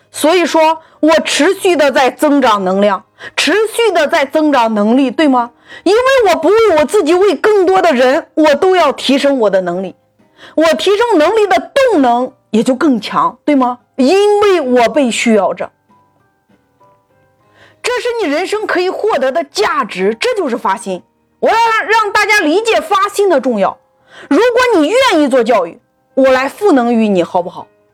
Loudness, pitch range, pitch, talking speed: -11 LUFS, 240-385 Hz, 305 Hz, 240 characters per minute